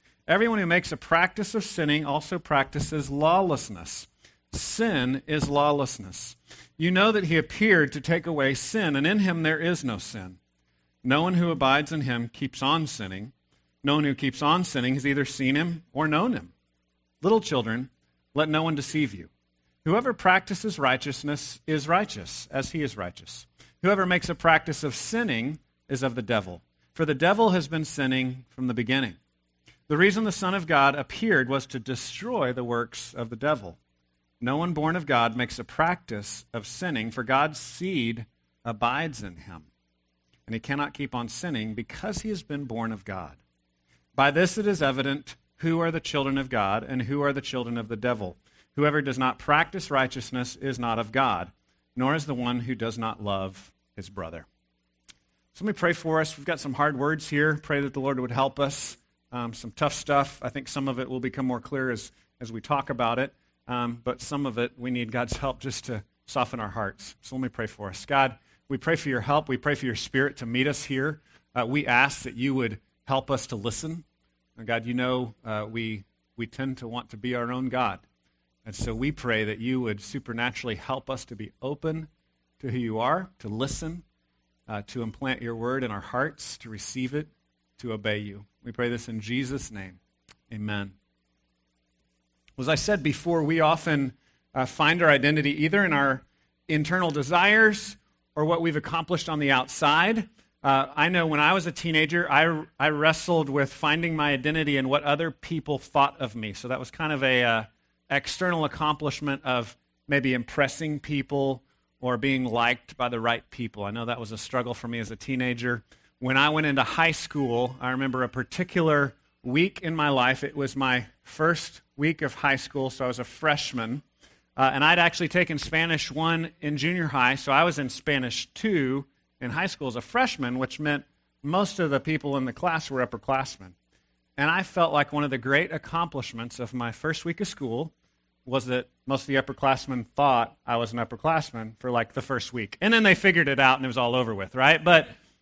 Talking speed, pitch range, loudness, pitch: 200 wpm, 115-150 Hz, -26 LUFS, 135 Hz